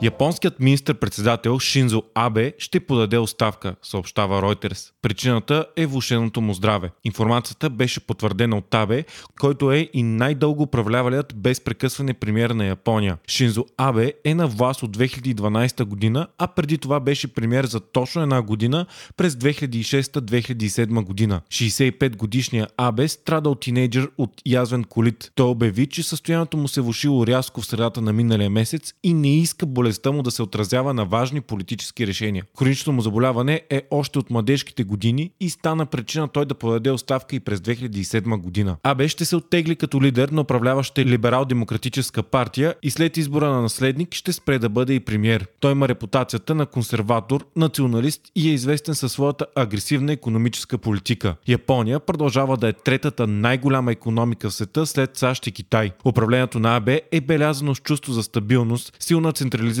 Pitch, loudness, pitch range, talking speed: 125 Hz, -21 LUFS, 115-145 Hz, 165 wpm